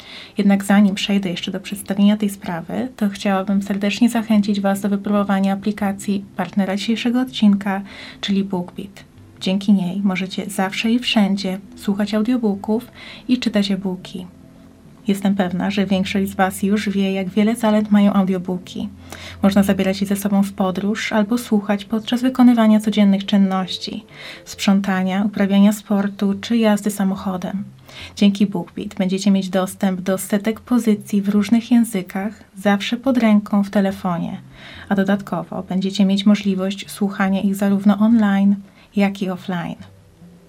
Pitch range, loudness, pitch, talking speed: 195-210 Hz, -19 LUFS, 200 Hz, 135 wpm